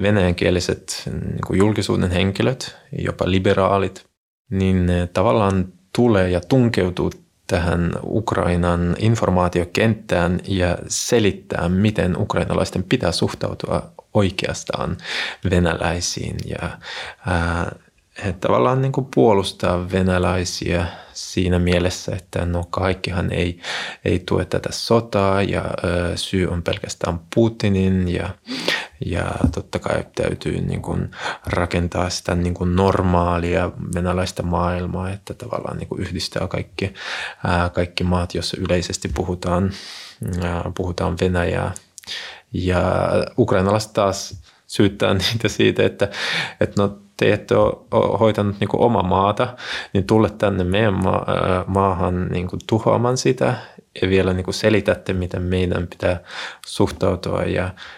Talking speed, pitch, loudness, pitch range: 115 wpm, 95 Hz, -20 LUFS, 90-100 Hz